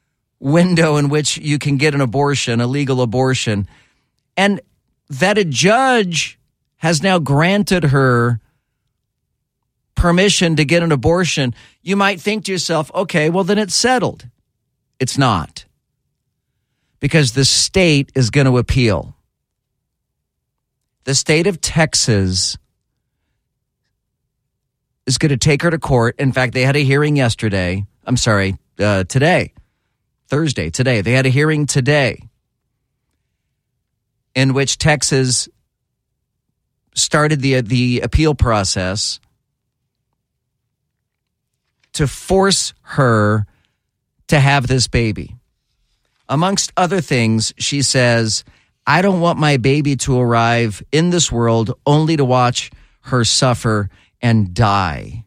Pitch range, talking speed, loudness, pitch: 115-150 Hz, 120 wpm, -15 LUFS, 130 Hz